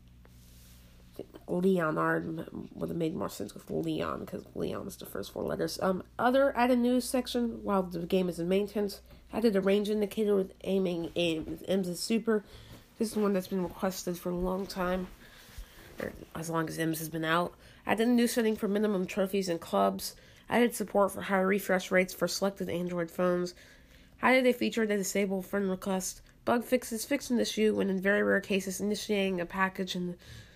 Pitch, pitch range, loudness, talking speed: 190 Hz, 170-210 Hz, -31 LUFS, 185 wpm